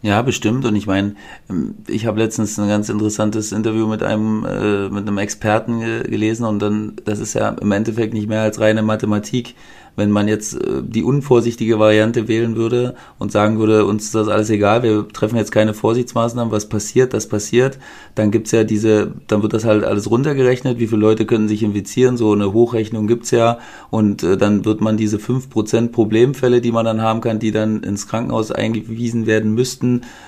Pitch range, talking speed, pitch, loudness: 105-115 Hz, 190 wpm, 110 Hz, -17 LUFS